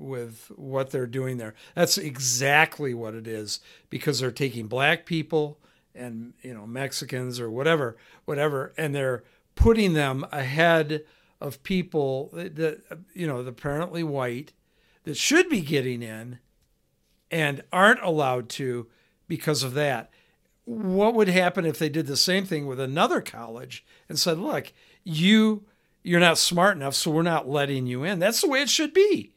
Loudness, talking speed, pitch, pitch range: -24 LUFS, 160 wpm, 150 Hz, 130-170 Hz